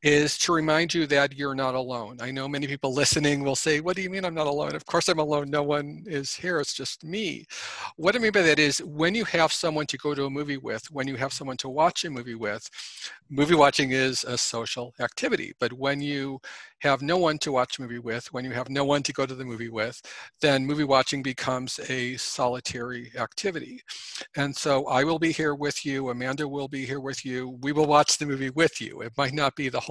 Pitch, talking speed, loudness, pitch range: 140 Hz, 240 wpm, -26 LUFS, 130-150 Hz